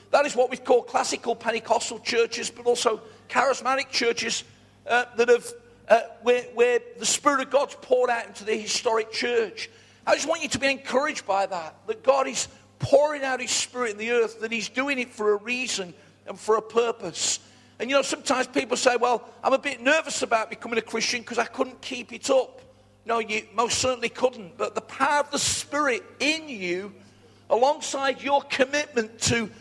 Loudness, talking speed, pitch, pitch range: -25 LUFS, 195 wpm, 245 Hz, 225-275 Hz